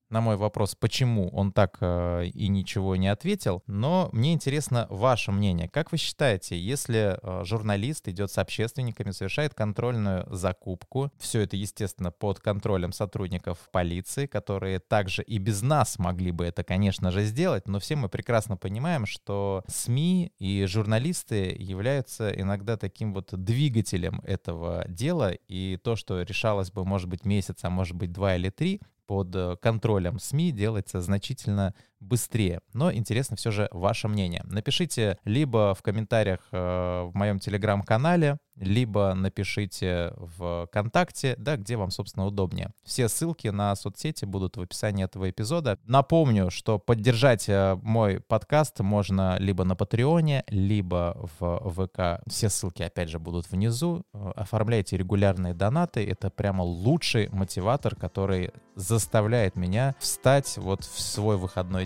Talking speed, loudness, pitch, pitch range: 140 wpm, -27 LUFS, 100 Hz, 95-115 Hz